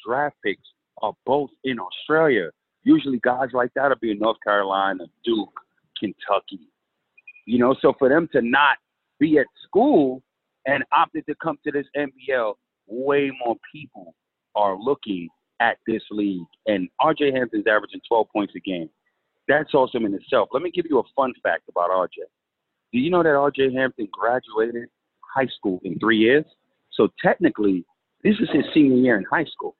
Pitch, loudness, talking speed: 135 Hz, -22 LUFS, 170 wpm